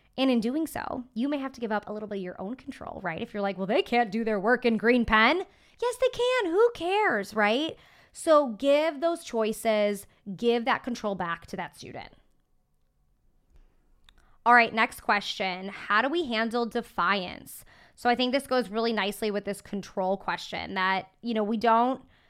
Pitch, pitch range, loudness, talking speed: 230 Hz, 200-260 Hz, -27 LUFS, 195 wpm